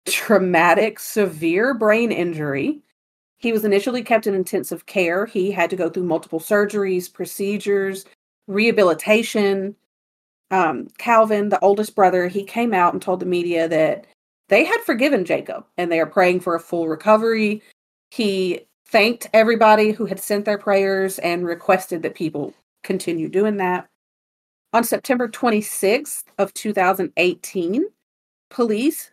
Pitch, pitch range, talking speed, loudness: 200 Hz, 180-215 Hz, 135 wpm, -19 LUFS